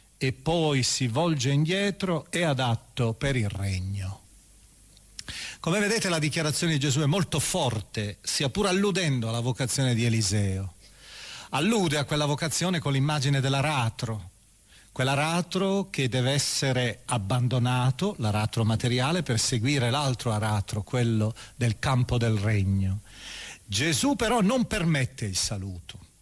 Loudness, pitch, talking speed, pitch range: -26 LUFS, 130 Hz, 130 wpm, 110-155 Hz